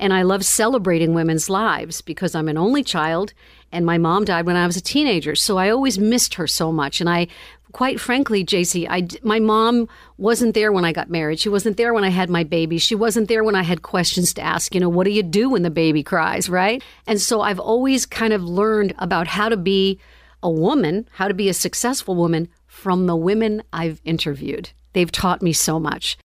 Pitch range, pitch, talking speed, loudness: 170-215 Hz, 185 Hz, 225 wpm, -19 LUFS